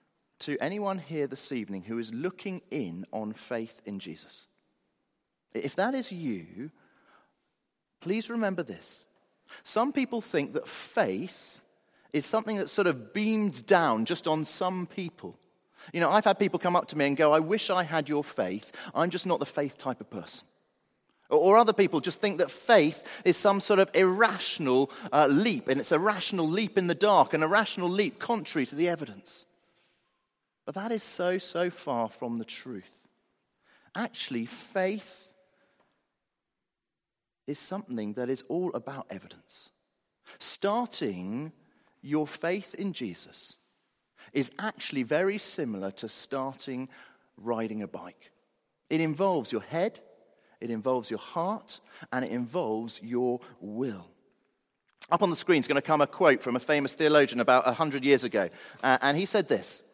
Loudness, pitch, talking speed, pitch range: -28 LUFS, 165 Hz, 155 wpm, 130-195 Hz